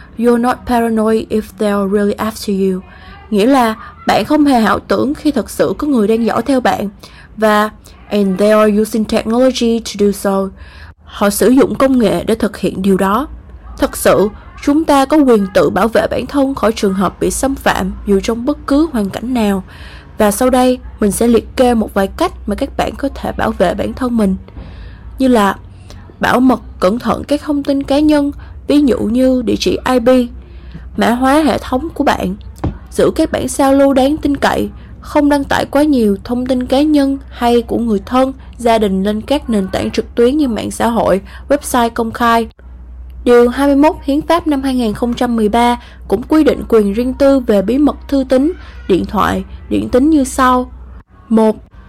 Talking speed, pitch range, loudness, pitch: 195 wpm, 210-275 Hz, -13 LUFS, 240 Hz